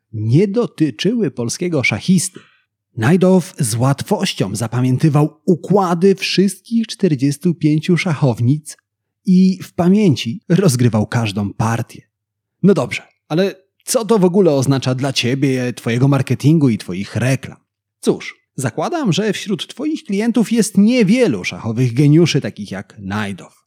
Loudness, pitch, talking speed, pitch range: -16 LUFS, 150 Hz, 115 wpm, 120-185 Hz